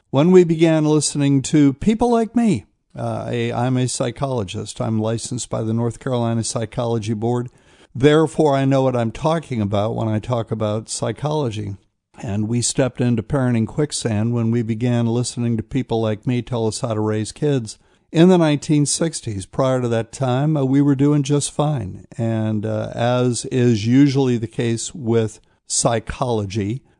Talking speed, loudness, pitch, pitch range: 165 wpm, -19 LUFS, 120 Hz, 115-140 Hz